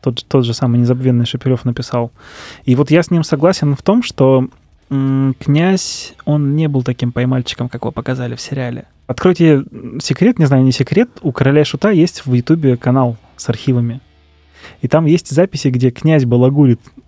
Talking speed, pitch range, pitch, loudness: 180 wpm, 125-150 Hz, 130 Hz, -14 LUFS